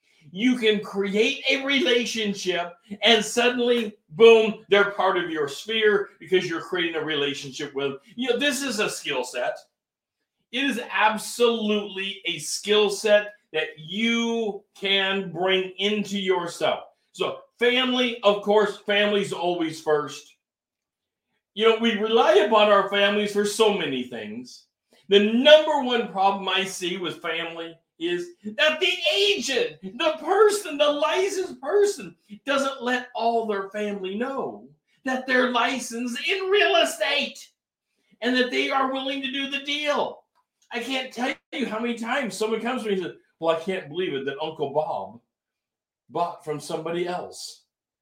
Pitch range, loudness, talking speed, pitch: 190-250 Hz, -23 LUFS, 150 wpm, 210 Hz